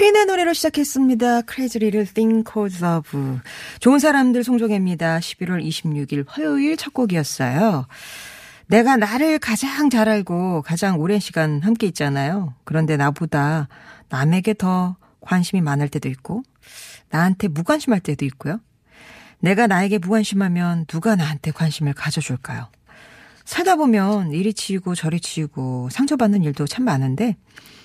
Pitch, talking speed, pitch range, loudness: 185 Hz, 340 characters per minute, 155-225 Hz, -20 LUFS